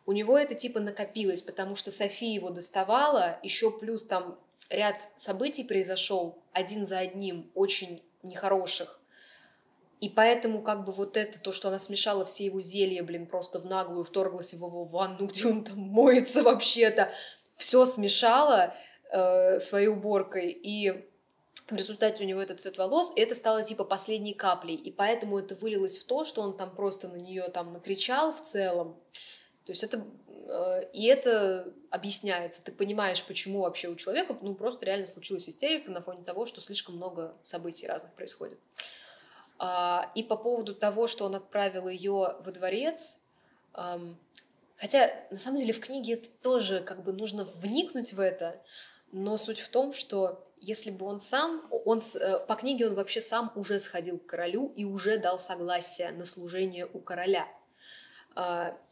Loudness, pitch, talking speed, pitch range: -29 LUFS, 200 Hz, 160 wpm, 185-225 Hz